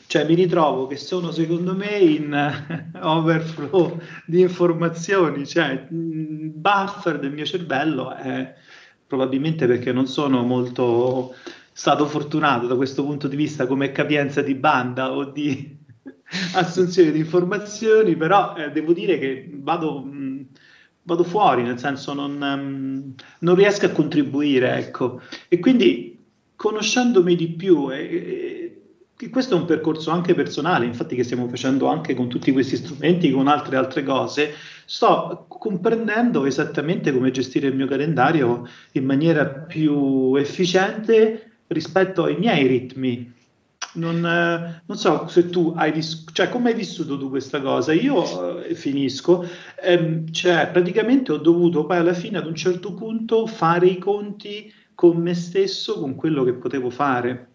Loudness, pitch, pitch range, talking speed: -21 LUFS, 160 Hz, 140-185 Hz, 145 wpm